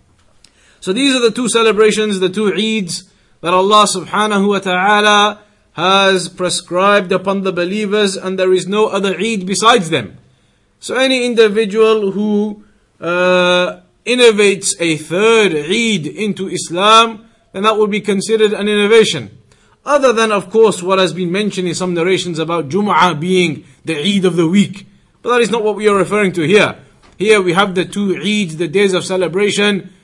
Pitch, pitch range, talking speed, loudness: 195 Hz, 180-210 Hz, 170 wpm, -13 LUFS